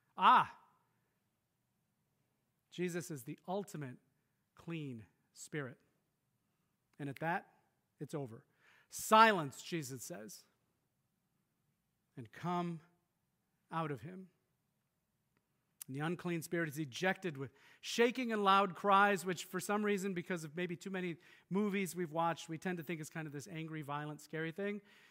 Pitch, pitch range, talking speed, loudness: 170 Hz, 155-190 Hz, 130 wpm, -37 LUFS